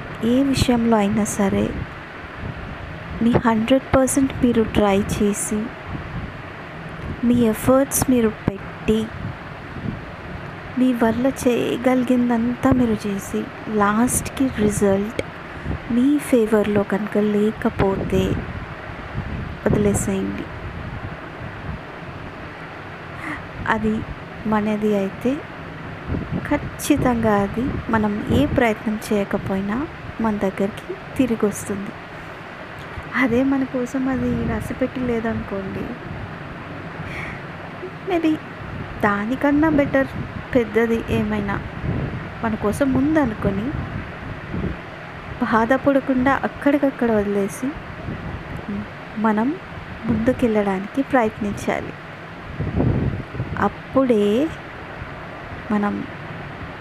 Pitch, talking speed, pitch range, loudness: 225 Hz, 65 wpm, 210-260 Hz, -21 LUFS